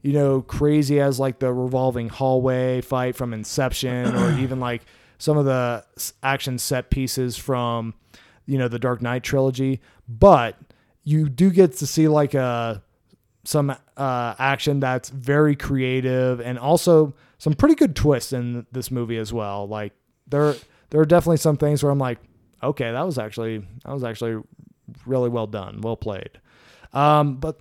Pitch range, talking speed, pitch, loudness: 120-145 Hz, 165 wpm, 130 Hz, -21 LUFS